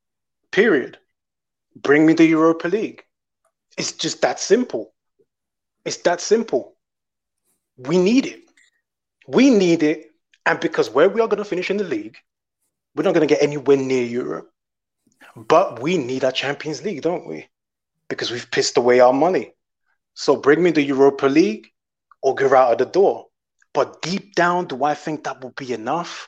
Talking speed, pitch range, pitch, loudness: 170 wpm, 140-205 Hz, 160 Hz, -19 LUFS